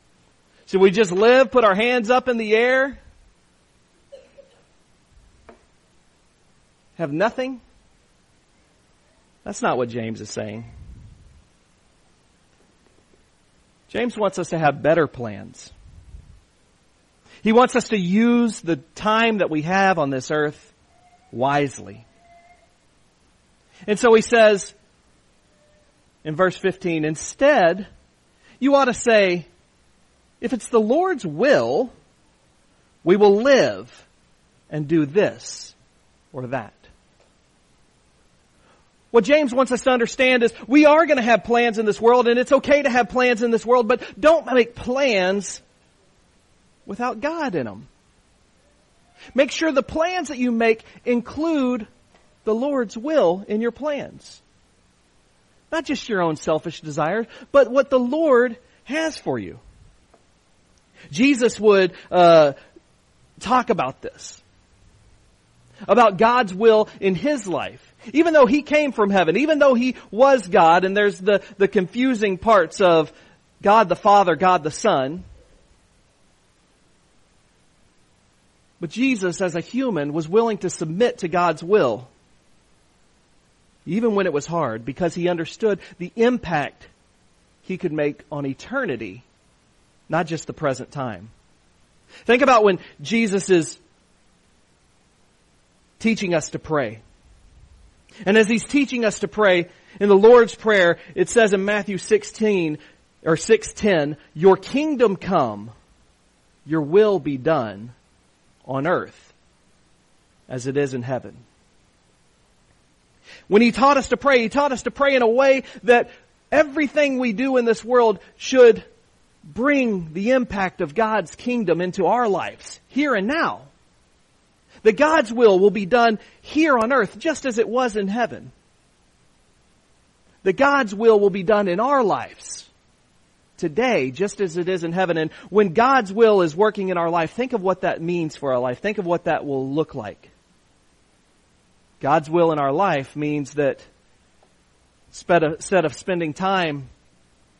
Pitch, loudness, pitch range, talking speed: 195 Hz, -19 LUFS, 145-240 Hz, 135 wpm